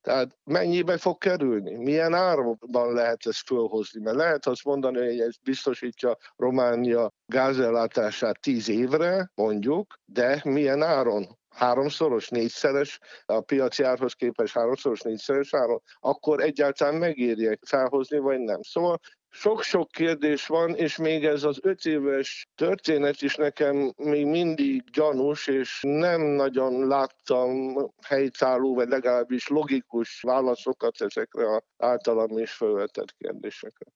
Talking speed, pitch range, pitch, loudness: 125 wpm, 125-160 Hz, 140 Hz, -26 LUFS